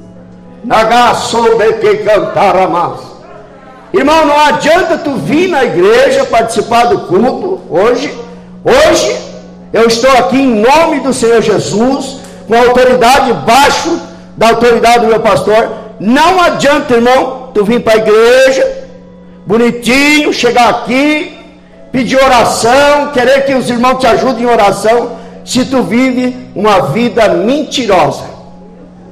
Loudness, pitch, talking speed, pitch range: -8 LUFS, 240 Hz, 115 wpm, 225-270 Hz